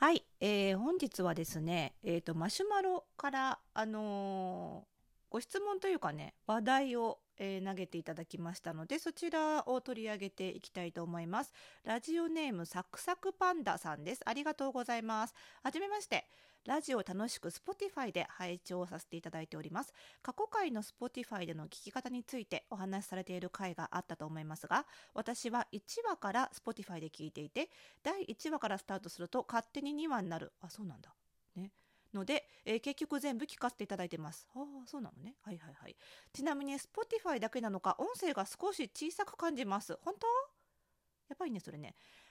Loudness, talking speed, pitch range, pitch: -40 LUFS, 400 characters per minute, 180-295 Hz, 225 Hz